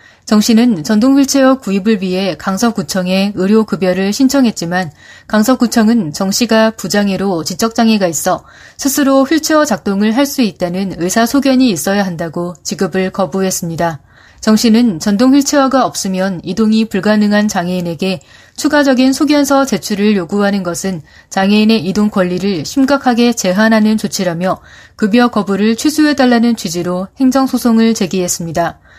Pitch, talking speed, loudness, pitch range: 210 Hz, 345 characters per minute, -12 LUFS, 185-240 Hz